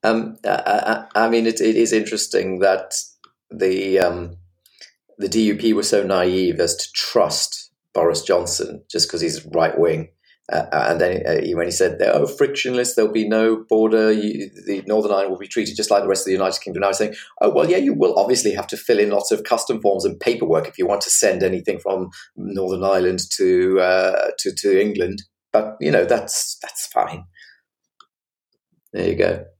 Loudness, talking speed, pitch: -19 LUFS, 200 wpm, 110 Hz